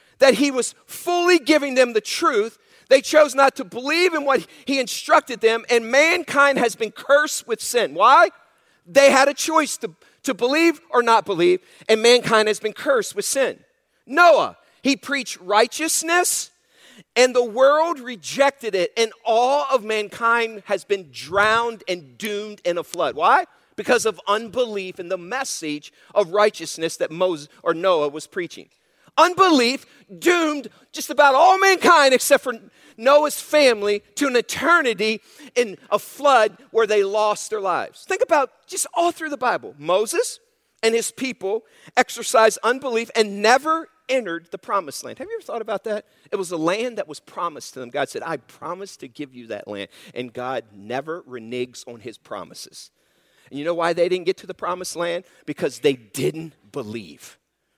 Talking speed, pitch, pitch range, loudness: 170 wpm, 240 Hz, 200-290 Hz, -20 LUFS